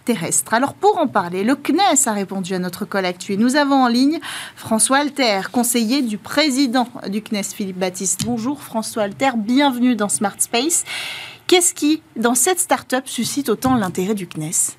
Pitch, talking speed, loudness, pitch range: 240 Hz, 170 wpm, -18 LUFS, 205-280 Hz